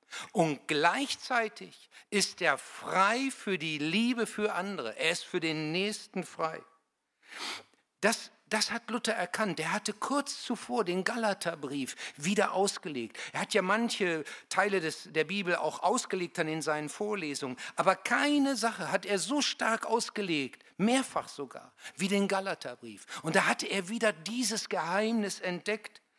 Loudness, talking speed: -31 LUFS, 145 wpm